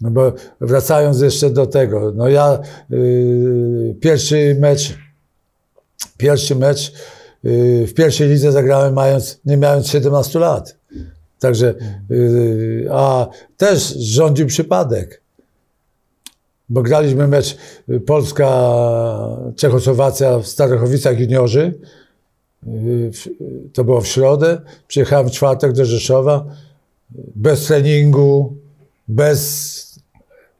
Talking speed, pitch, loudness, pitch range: 100 wpm, 135 Hz, -14 LUFS, 125-145 Hz